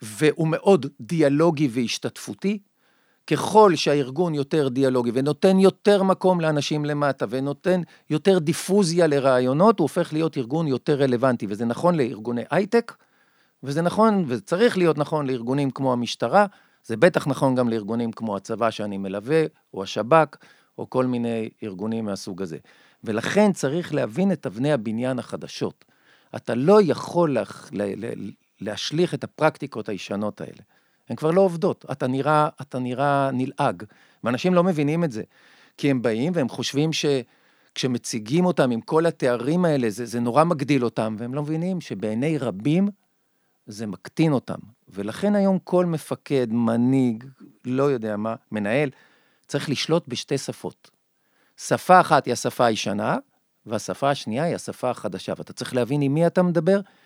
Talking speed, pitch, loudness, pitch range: 145 wpm, 145 Hz, -23 LUFS, 120-175 Hz